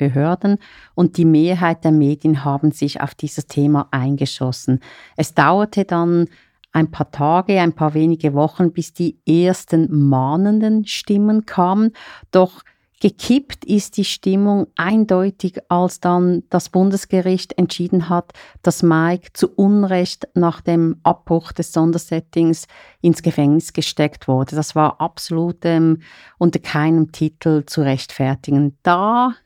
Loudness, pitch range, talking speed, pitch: -17 LUFS, 155-185 Hz, 130 wpm, 170 Hz